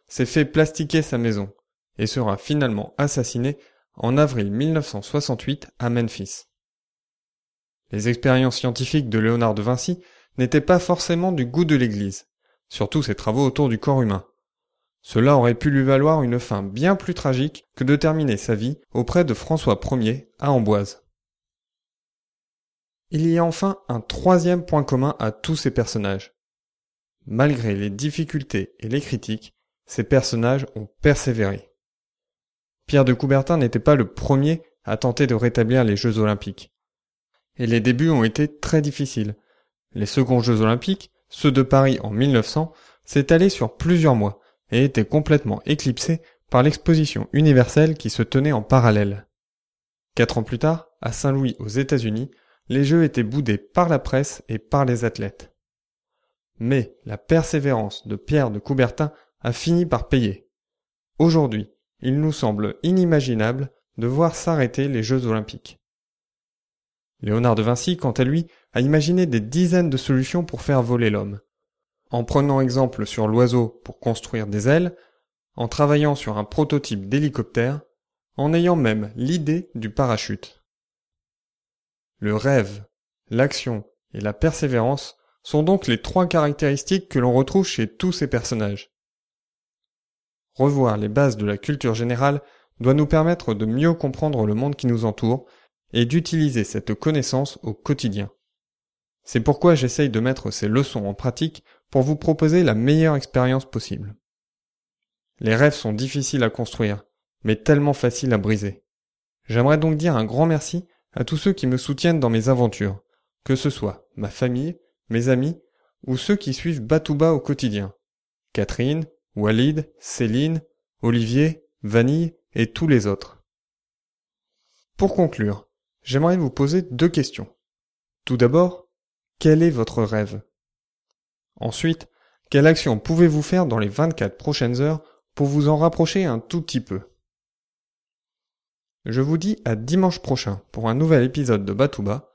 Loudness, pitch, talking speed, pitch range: -21 LUFS, 130 Hz, 150 wpm, 115-155 Hz